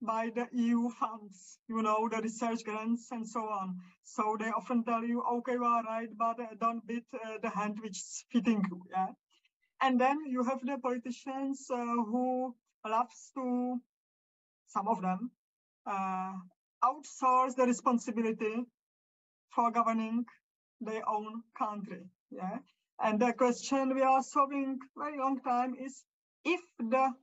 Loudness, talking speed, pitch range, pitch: -34 LUFS, 150 wpm, 220-255 Hz, 235 Hz